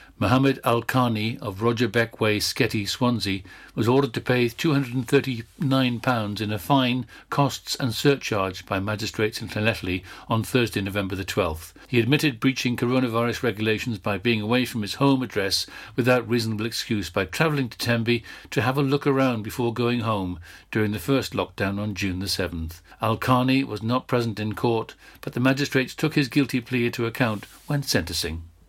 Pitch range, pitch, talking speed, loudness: 105-130 Hz, 120 Hz, 175 wpm, -24 LUFS